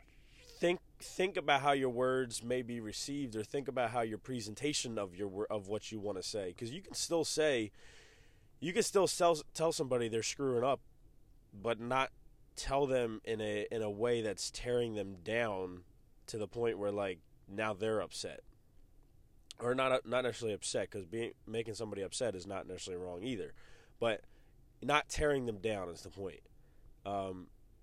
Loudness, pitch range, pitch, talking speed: -37 LUFS, 105-135 Hz, 115 Hz, 175 wpm